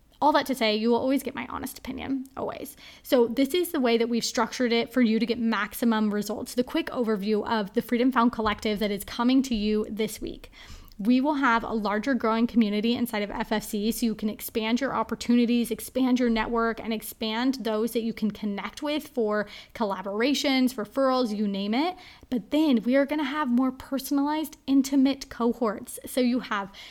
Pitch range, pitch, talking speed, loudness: 220-260 Hz, 235 Hz, 200 wpm, -26 LUFS